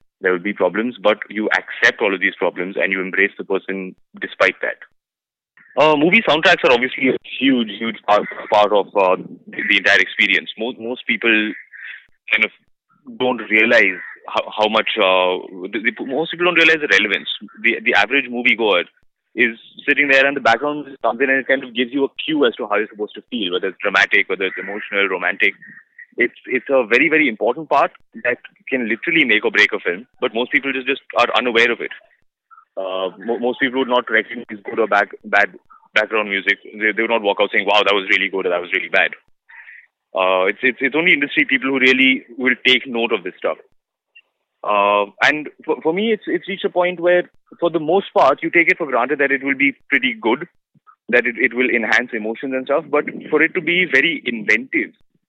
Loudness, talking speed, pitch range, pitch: -17 LUFS, 215 wpm, 110-150 Hz, 130 Hz